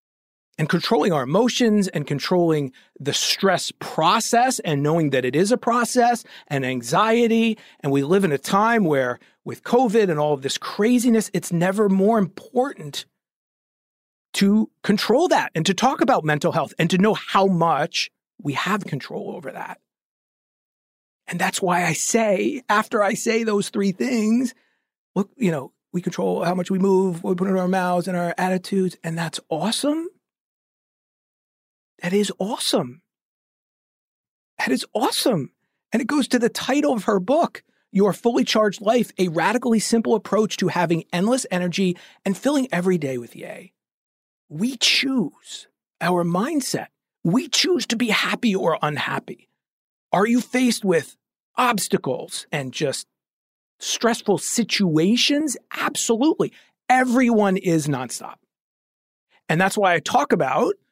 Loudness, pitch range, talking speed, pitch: -21 LUFS, 175-235 Hz, 150 wpm, 200 Hz